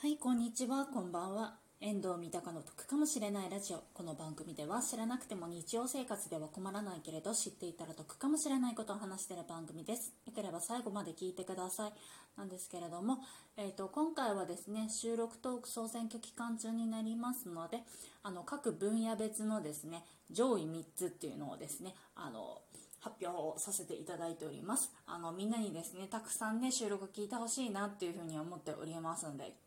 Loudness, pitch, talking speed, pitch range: -41 LUFS, 205 Hz, 425 characters per minute, 175-230 Hz